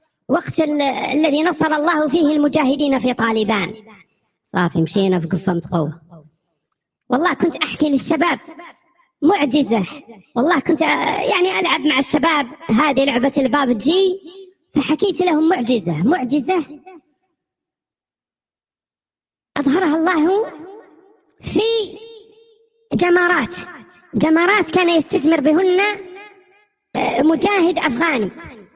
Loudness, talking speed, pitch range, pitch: -17 LUFS, 90 wpm, 270-365 Hz, 315 Hz